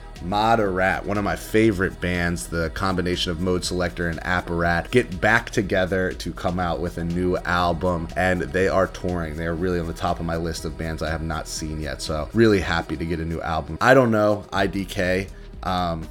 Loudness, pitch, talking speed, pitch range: -23 LUFS, 90 Hz, 210 wpm, 85-95 Hz